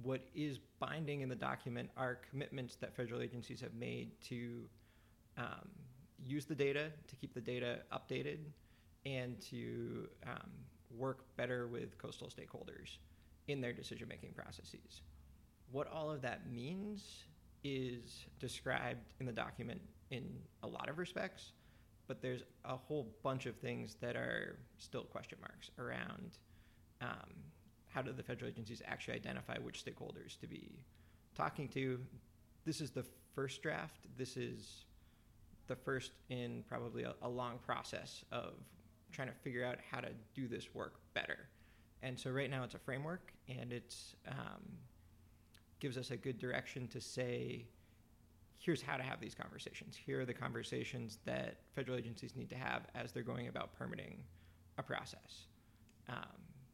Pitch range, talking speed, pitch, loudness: 105-130 Hz, 155 wpm, 125 Hz, -46 LUFS